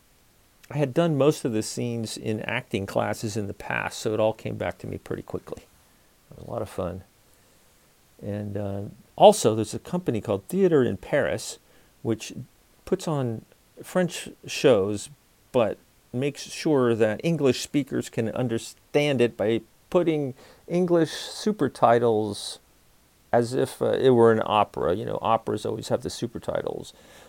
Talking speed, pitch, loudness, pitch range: 155 wpm, 115 Hz, -25 LUFS, 105-145 Hz